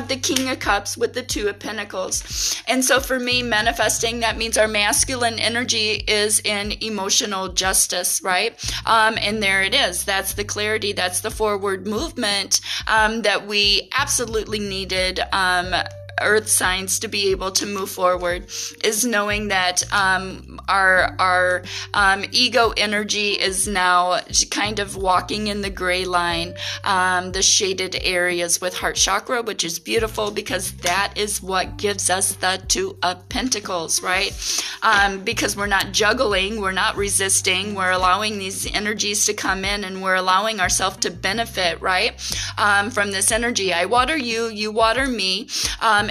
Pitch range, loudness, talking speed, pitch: 185-220 Hz, -19 LUFS, 160 wpm, 205 Hz